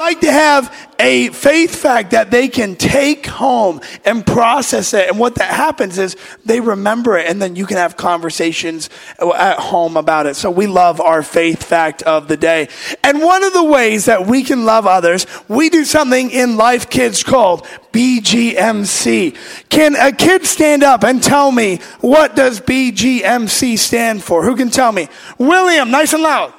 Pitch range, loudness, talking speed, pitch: 185-285 Hz, -12 LUFS, 180 wpm, 235 Hz